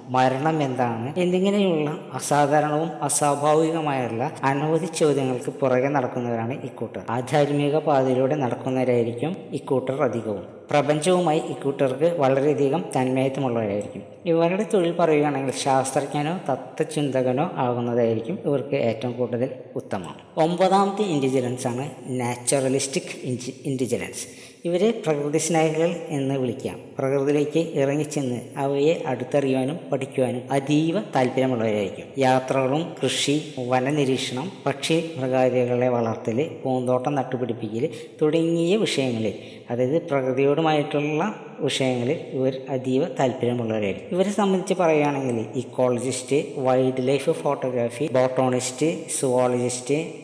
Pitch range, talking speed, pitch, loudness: 125-155 Hz, 85 wpm, 135 Hz, -23 LUFS